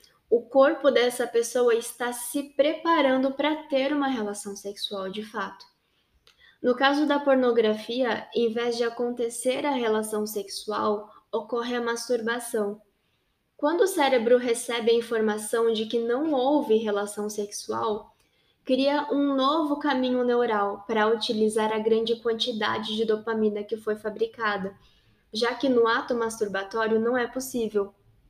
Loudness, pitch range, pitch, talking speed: -26 LUFS, 215-260 Hz, 235 Hz, 135 wpm